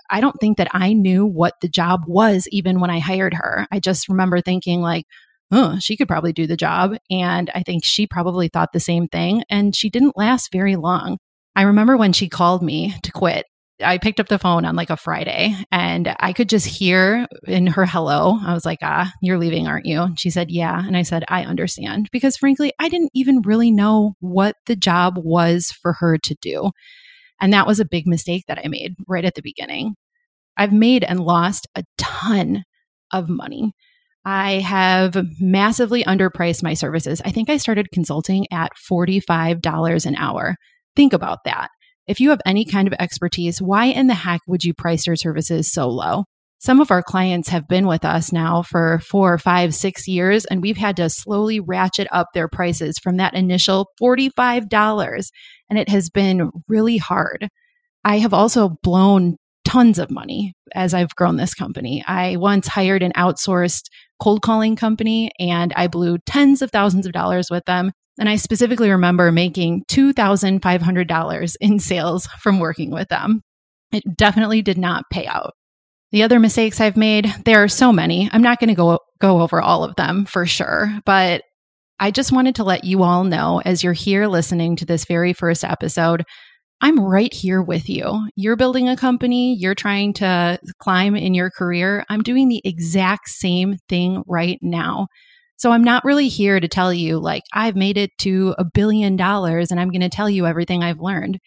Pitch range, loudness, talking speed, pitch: 175-215 Hz, -18 LUFS, 190 wpm, 190 Hz